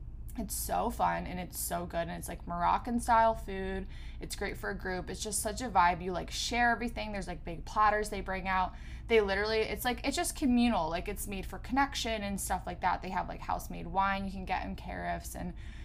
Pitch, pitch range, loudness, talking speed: 195 Hz, 175-225 Hz, -33 LUFS, 235 wpm